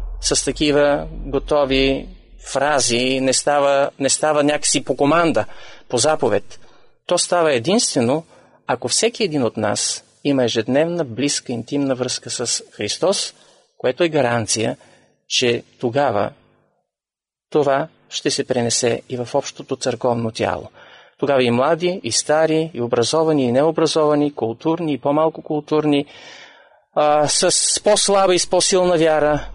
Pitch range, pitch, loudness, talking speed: 125-160 Hz, 145 Hz, -18 LUFS, 125 wpm